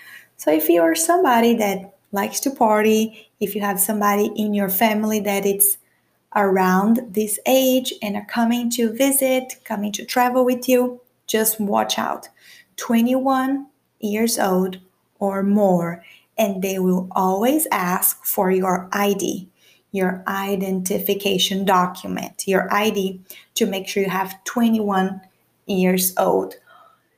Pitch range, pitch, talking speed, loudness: 190-230 Hz, 205 Hz, 130 wpm, -20 LUFS